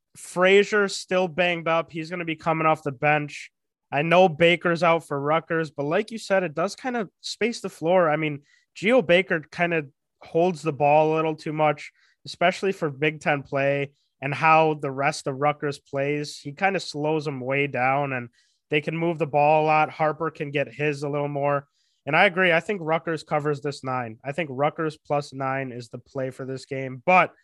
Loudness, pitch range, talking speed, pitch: -24 LUFS, 145-170 Hz, 210 wpm, 155 Hz